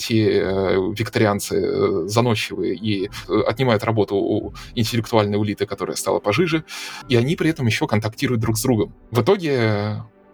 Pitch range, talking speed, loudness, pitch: 105-130 Hz, 135 wpm, -21 LUFS, 115 Hz